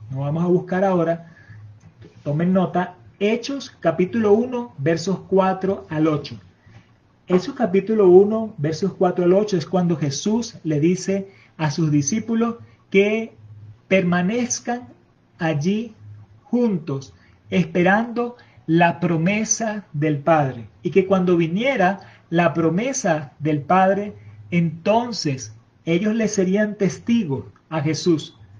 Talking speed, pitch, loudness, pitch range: 110 wpm, 175 Hz, -20 LUFS, 145-200 Hz